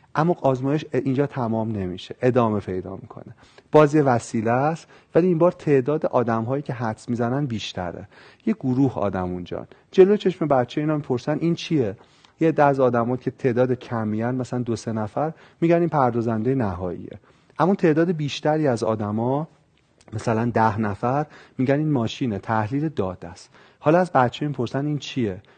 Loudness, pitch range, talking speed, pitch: -22 LUFS, 110-150 Hz, 155 wpm, 130 Hz